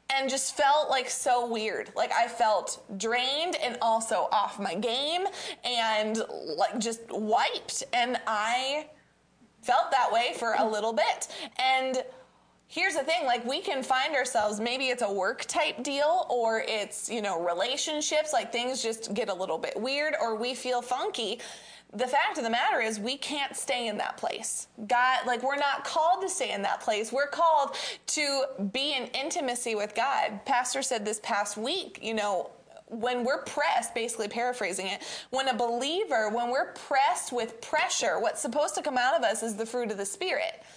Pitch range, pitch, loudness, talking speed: 225-285 Hz, 250 Hz, -28 LUFS, 185 wpm